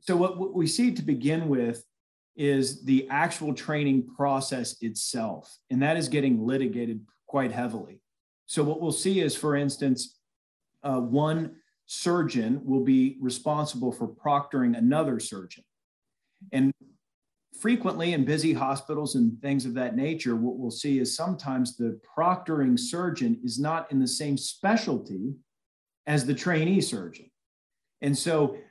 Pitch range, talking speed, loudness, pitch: 130-170 Hz, 140 wpm, -27 LUFS, 145 Hz